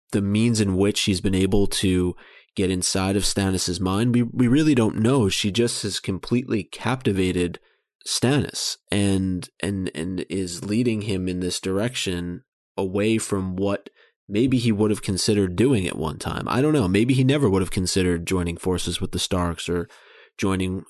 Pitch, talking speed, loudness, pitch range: 95 Hz, 175 wpm, -23 LUFS, 95-110 Hz